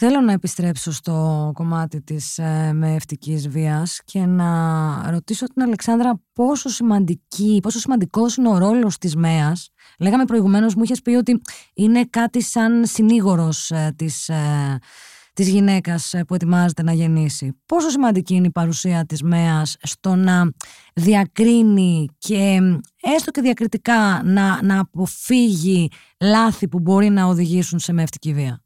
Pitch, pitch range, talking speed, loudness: 185 Hz, 160-220 Hz, 135 wpm, -18 LUFS